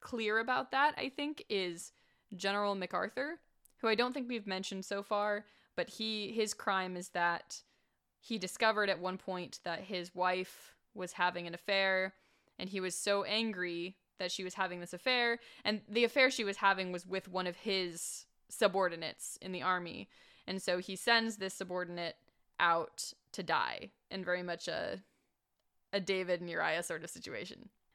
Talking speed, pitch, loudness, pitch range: 170 wpm, 190 Hz, -36 LUFS, 180-215 Hz